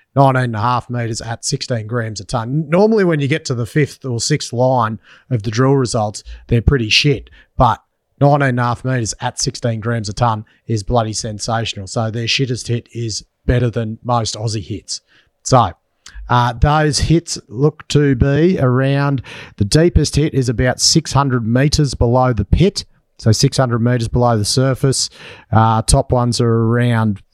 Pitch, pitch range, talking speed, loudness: 125 Hz, 115-135 Hz, 160 wpm, -16 LUFS